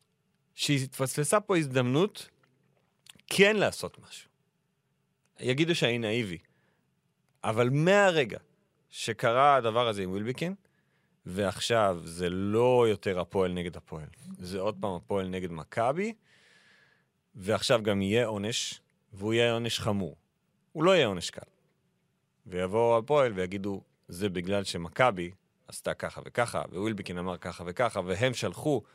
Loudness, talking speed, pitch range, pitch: -29 LUFS, 120 wpm, 95-130 Hz, 110 Hz